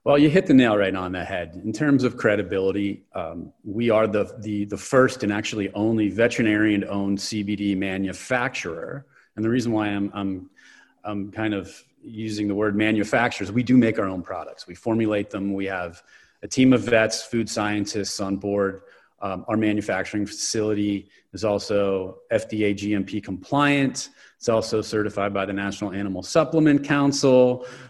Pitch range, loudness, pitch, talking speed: 100-115 Hz, -23 LUFS, 105 Hz, 165 wpm